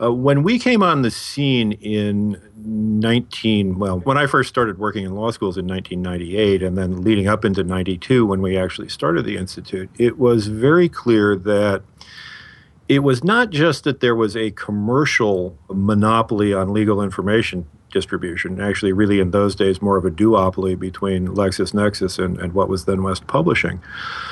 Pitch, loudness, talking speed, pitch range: 105 Hz, -18 LUFS, 170 wpm, 95-115 Hz